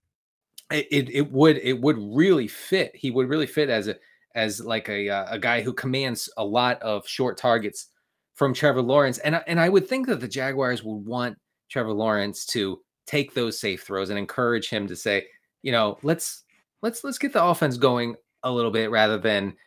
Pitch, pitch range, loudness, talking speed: 125 Hz, 110-145 Hz, -24 LUFS, 200 wpm